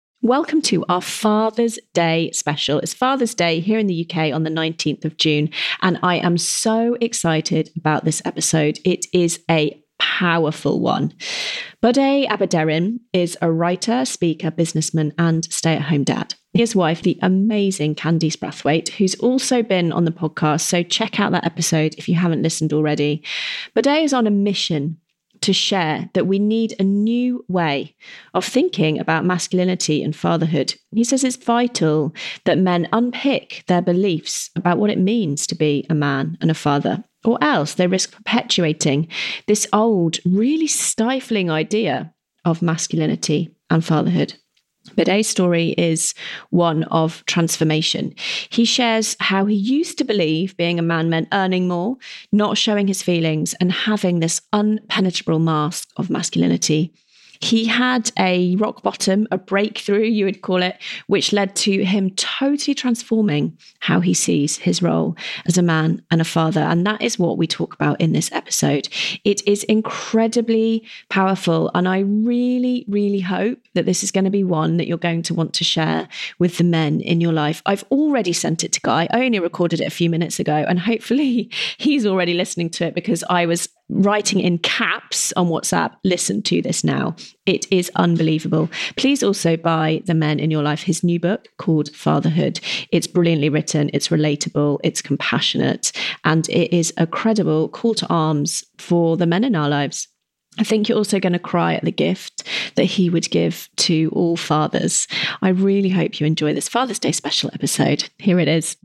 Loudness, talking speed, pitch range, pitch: -19 LUFS, 175 wpm, 160-210 Hz, 175 Hz